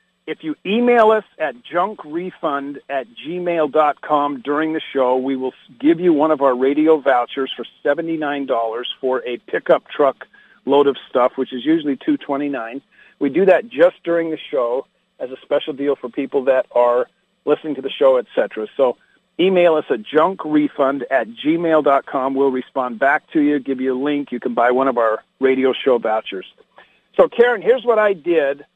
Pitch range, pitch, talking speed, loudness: 130-175 Hz, 145 Hz, 175 wpm, -18 LUFS